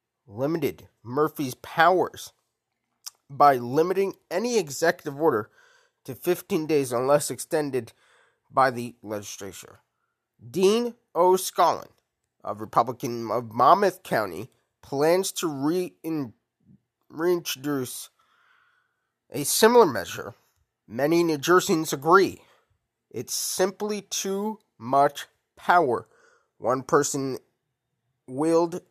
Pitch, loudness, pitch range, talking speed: 160 Hz, -24 LUFS, 130-195 Hz, 85 wpm